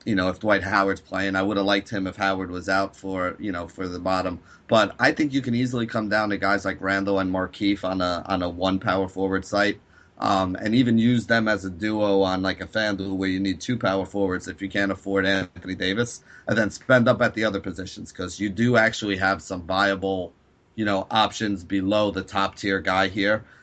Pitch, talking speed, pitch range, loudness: 95 Hz, 230 wpm, 95-105 Hz, -24 LUFS